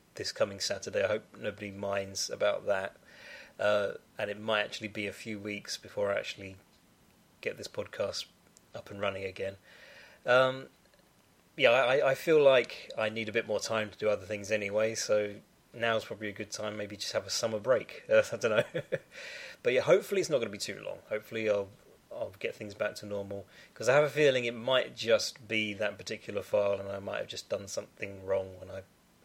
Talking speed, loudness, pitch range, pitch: 205 wpm, -31 LUFS, 100-115 Hz, 105 Hz